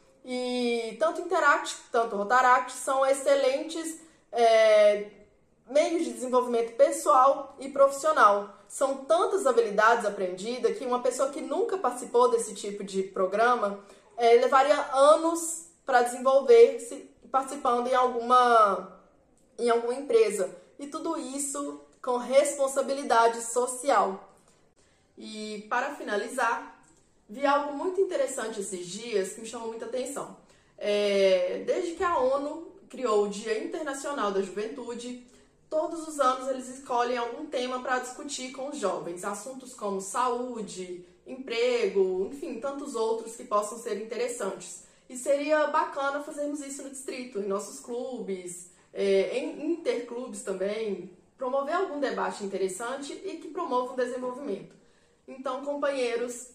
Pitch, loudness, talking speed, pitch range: 255 Hz, -27 LUFS, 125 wpm, 220-285 Hz